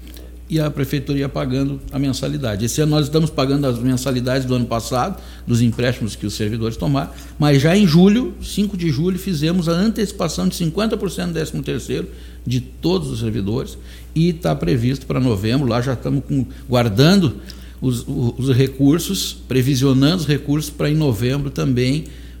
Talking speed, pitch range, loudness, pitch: 165 wpm, 125-155 Hz, -19 LUFS, 135 Hz